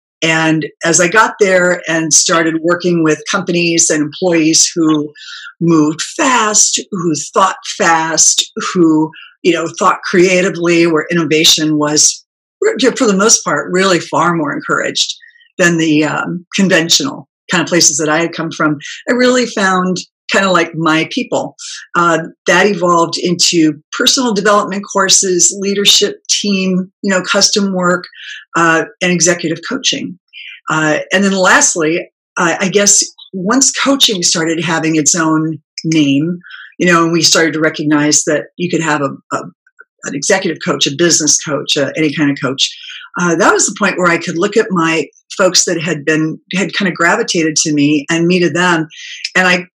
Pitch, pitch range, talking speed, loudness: 170 Hz, 160-195 Hz, 165 wpm, -12 LUFS